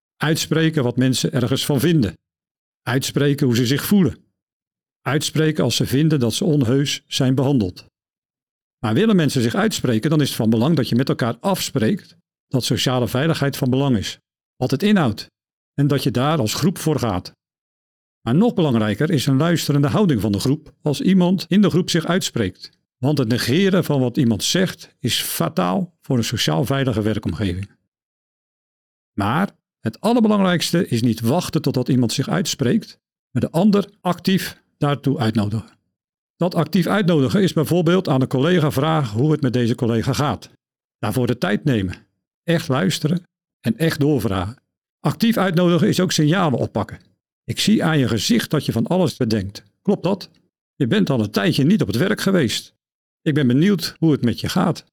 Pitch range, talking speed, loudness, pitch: 125-170 Hz, 175 wpm, -19 LUFS, 145 Hz